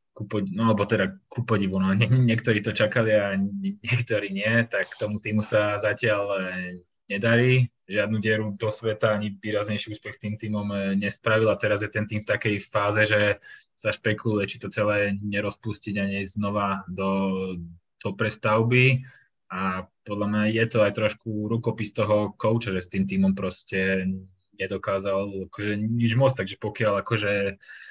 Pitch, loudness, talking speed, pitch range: 105 Hz, -25 LUFS, 155 wpm, 100-110 Hz